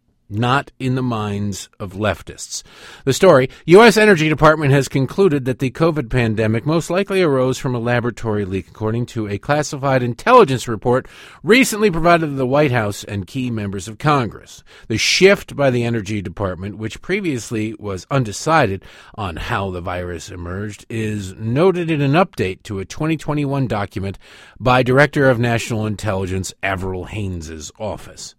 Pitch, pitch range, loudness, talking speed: 120 Hz, 100-145 Hz, -17 LUFS, 155 wpm